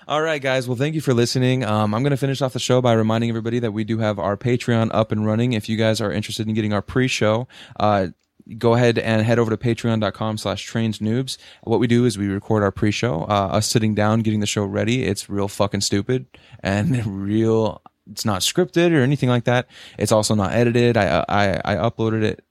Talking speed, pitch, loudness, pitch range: 225 wpm, 110 Hz, -20 LUFS, 105-120 Hz